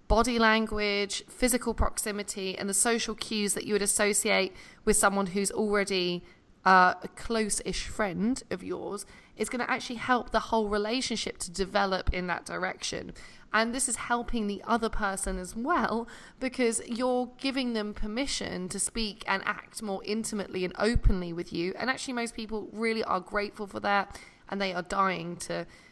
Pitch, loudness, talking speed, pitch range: 210 Hz, -29 LUFS, 170 wpm, 195-230 Hz